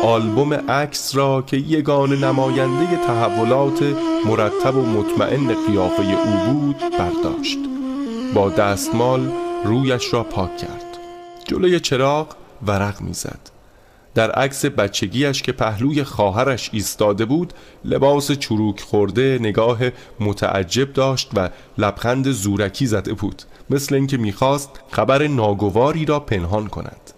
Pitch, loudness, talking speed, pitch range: 130 Hz, -19 LUFS, 115 wpm, 105-145 Hz